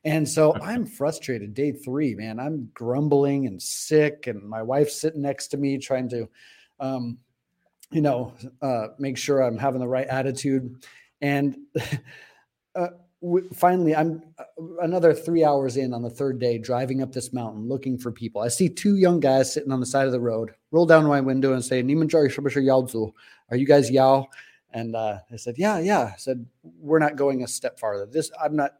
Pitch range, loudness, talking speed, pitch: 125-150 Hz, -24 LUFS, 185 wpm, 135 Hz